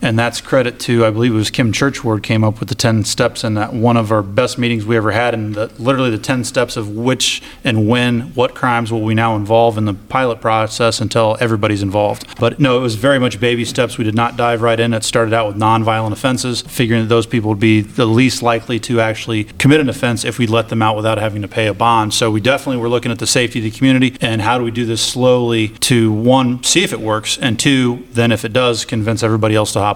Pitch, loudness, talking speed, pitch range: 115 Hz, -15 LUFS, 260 wpm, 110-125 Hz